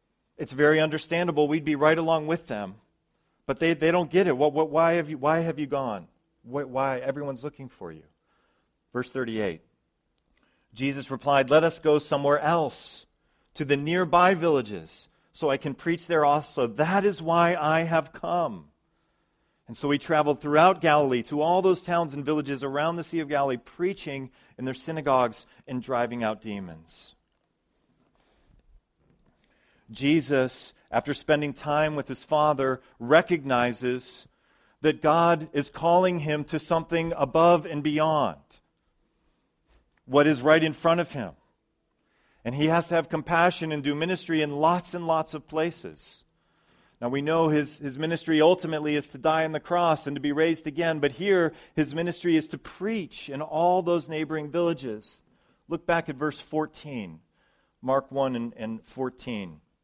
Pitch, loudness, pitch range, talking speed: 150 Hz, -25 LUFS, 135-165 Hz, 160 wpm